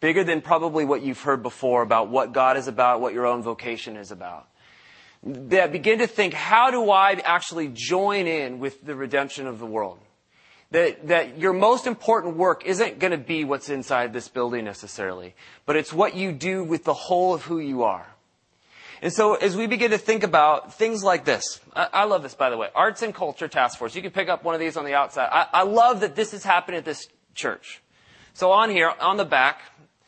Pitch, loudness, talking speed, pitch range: 165 Hz, -22 LUFS, 220 wpm, 135-195 Hz